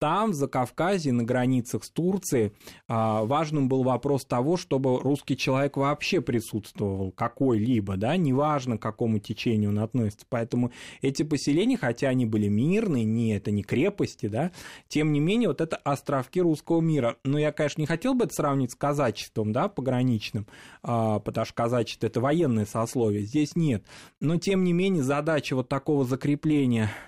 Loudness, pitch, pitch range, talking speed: -26 LUFS, 135 Hz, 115-150 Hz, 160 wpm